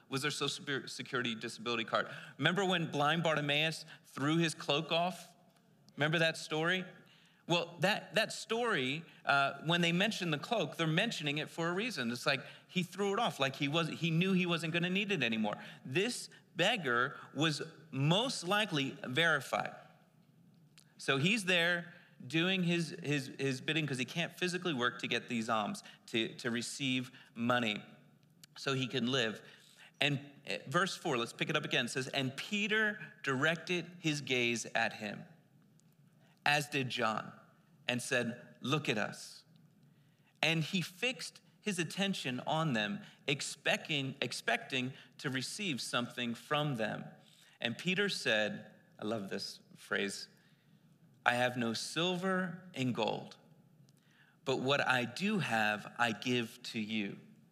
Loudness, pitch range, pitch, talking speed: -35 LUFS, 130-175 Hz, 160 Hz, 150 wpm